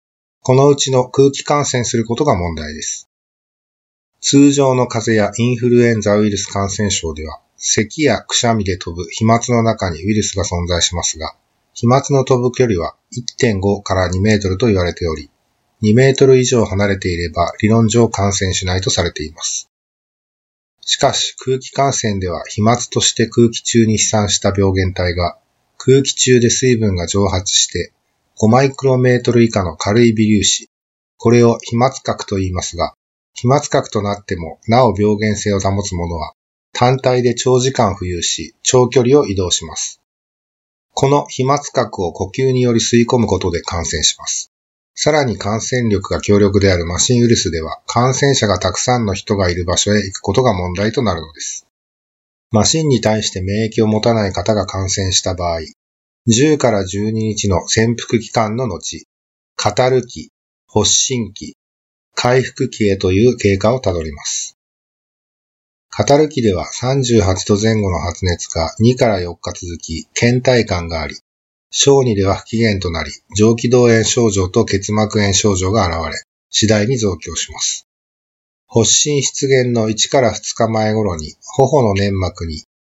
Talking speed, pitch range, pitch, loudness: 300 characters per minute, 95-120 Hz, 105 Hz, -15 LUFS